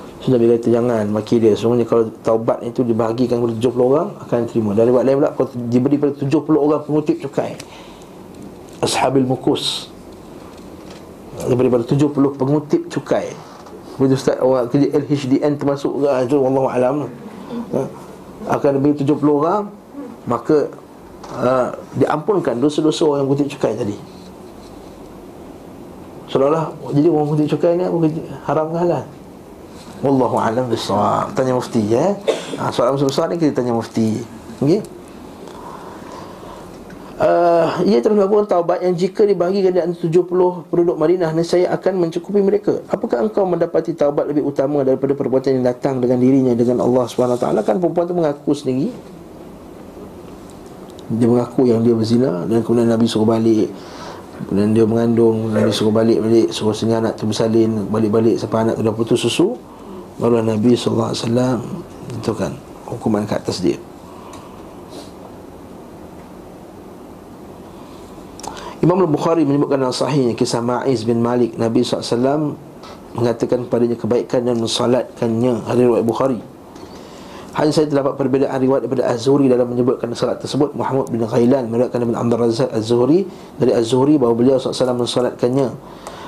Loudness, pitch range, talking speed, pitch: -17 LUFS, 120-150 Hz, 140 wpm, 130 Hz